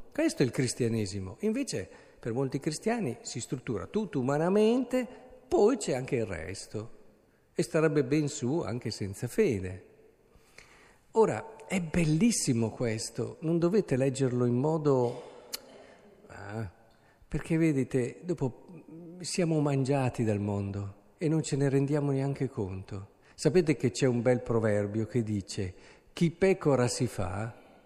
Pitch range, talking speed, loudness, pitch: 115-165 Hz, 130 wpm, -30 LUFS, 135 Hz